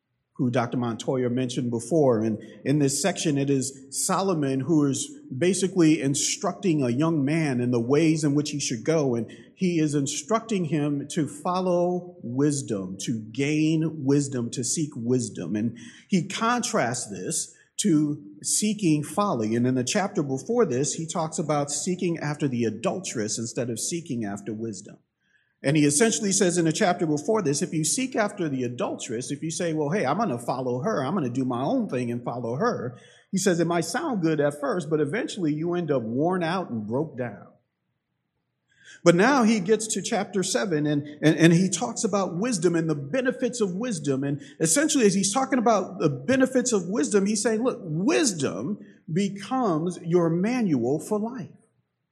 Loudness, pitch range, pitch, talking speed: -25 LUFS, 135-190 Hz, 155 Hz, 180 wpm